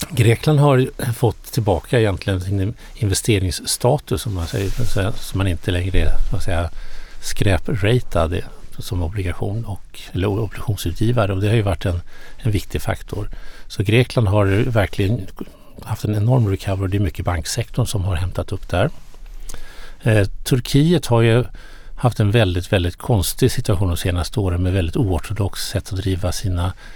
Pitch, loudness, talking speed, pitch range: 100 Hz, -20 LUFS, 145 wpm, 95-115 Hz